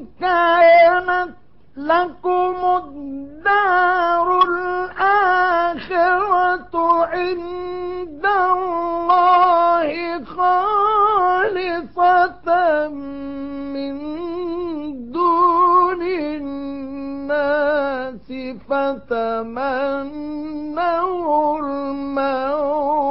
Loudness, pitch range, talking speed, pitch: -18 LUFS, 285-360 Hz, 30 wpm, 340 Hz